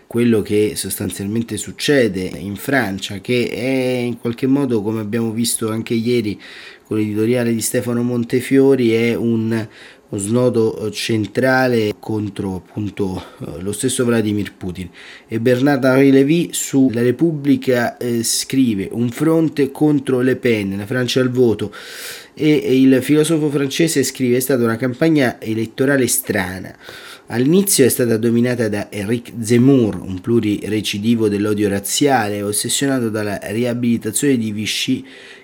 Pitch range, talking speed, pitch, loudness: 105-130 Hz, 130 wpm, 120 Hz, -17 LUFS